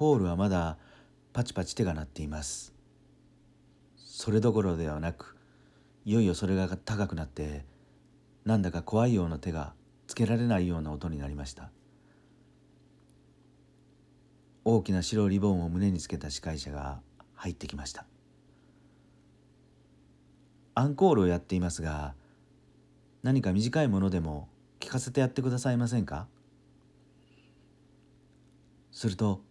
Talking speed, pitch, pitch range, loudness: 265 characters per minute, 90 Hz, 75-115 Hz, -30 LUFS